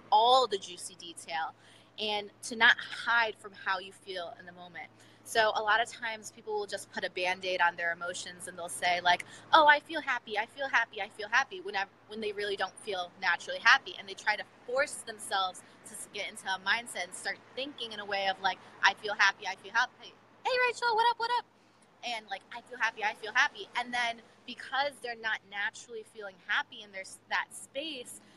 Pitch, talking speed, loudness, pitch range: 210 Hz, 220 wpm, -31 LUFS, 190-255 Hz